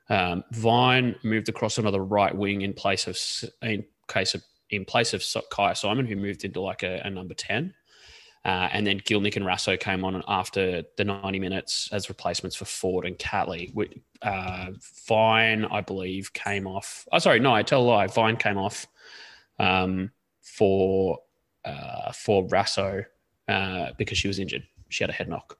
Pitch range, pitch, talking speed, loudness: 95-105 Hz, 100 Hz, 175 wpm, -26 LUFS